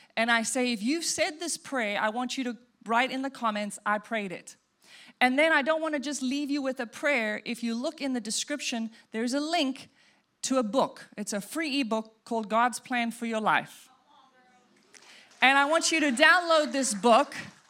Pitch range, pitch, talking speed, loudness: 230-290 Hz, 250 Hz, 205 wpm, -27 LUFS